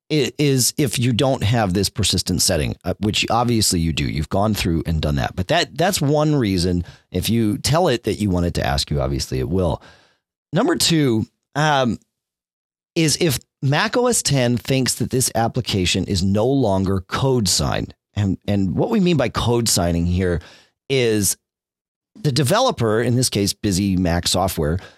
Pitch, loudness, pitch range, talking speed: 100 Hz, -19 LUFS, 90-125 Hz, 175 wpm